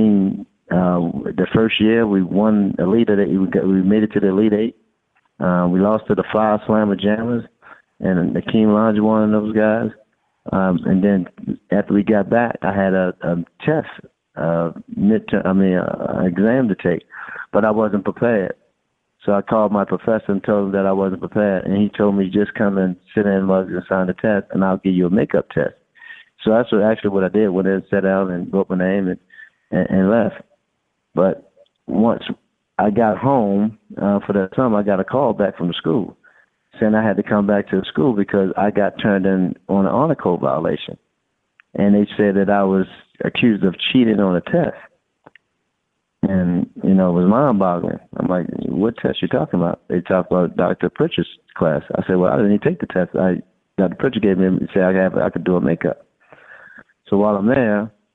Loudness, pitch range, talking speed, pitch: -18 LUFS, 95-110 Hz, 205 wpm, 100 Hz